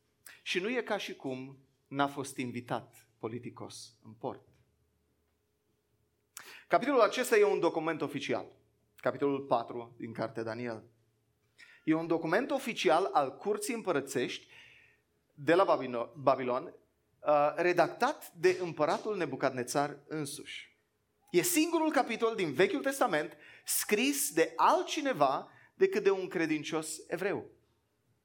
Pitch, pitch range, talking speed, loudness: 155 Hz, 130-215 Hz, 115 wpm, -31 LUFS